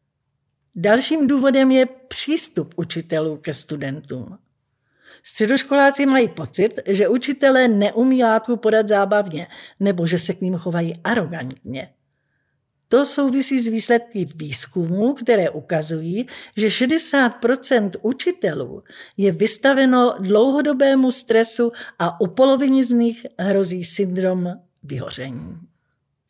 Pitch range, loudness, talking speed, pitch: 165-255 Hz, -18 LUFS, 105 wpm, 210 Hz